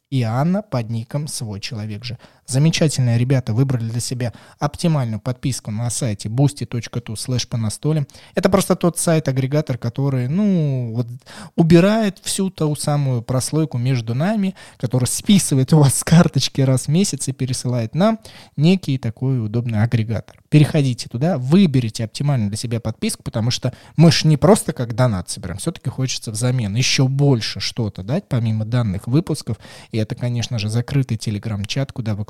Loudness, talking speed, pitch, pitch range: -19 LUFS, 150 wpm, 130 Hz, 115-150 Hz